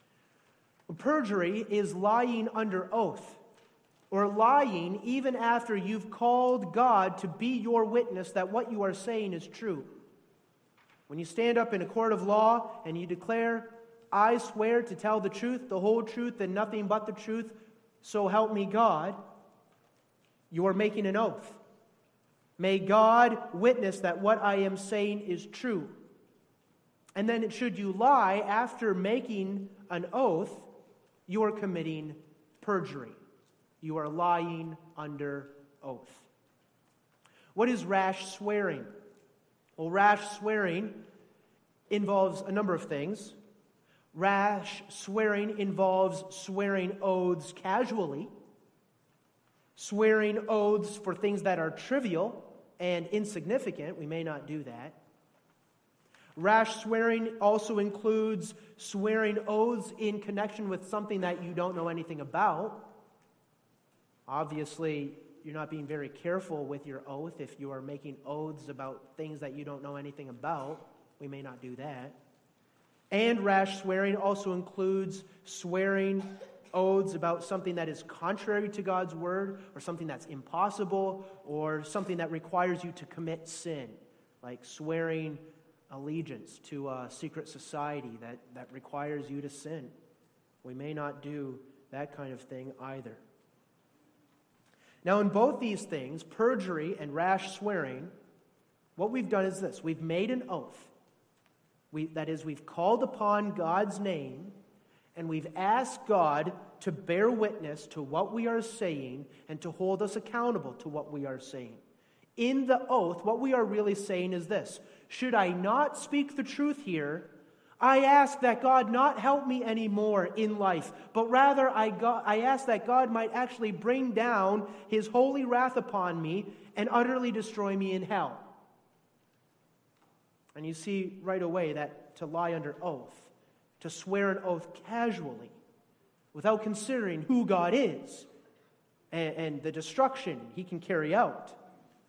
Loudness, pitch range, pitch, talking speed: -31 LUFS, 160-220 Hz, 195 Hz, 140 wpm